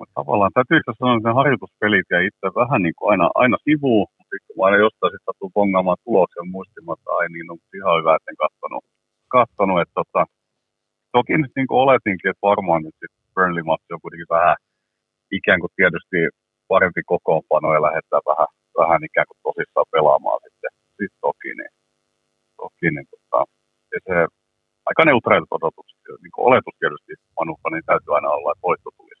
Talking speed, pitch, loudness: 175 wpm, 125 Hz, -19 LUFS